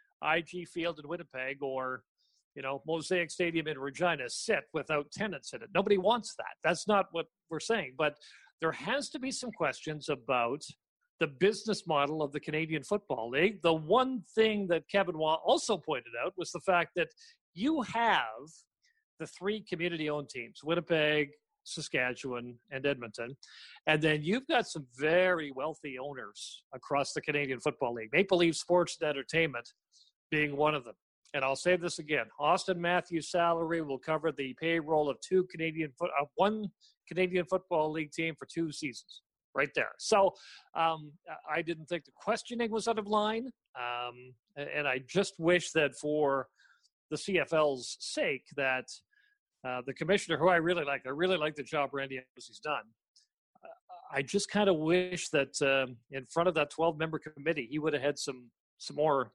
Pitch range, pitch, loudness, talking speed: 145-185 Hz, 160 Hz, -32 LUFS, 170 wpm